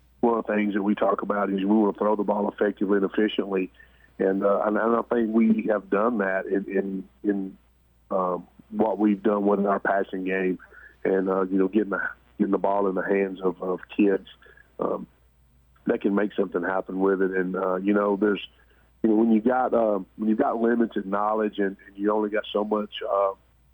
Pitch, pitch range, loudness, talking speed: 100 Hz, 95-105 Hz, -25 LUFS, 220 wpm